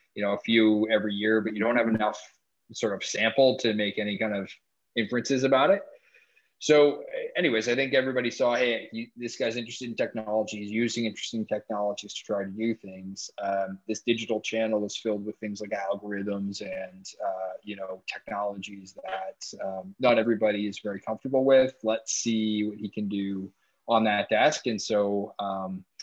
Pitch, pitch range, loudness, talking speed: 110 Hz, 100-115 Hz, -27 LUFS, 180 wpm